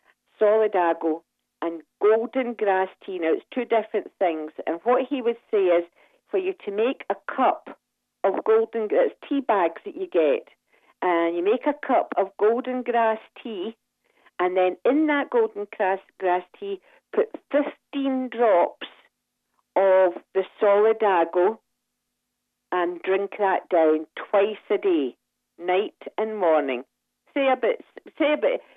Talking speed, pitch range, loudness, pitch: 145 wpm, 185-295 Hz, -24 LUFS, 220 Hz